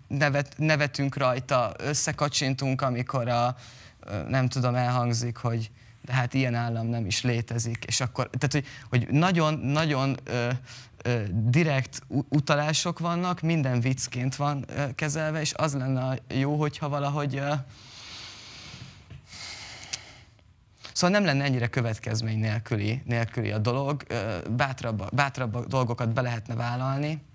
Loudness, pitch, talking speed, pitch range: -27 LUFS, 130 Hz, 120 wpm, 120-145 Hz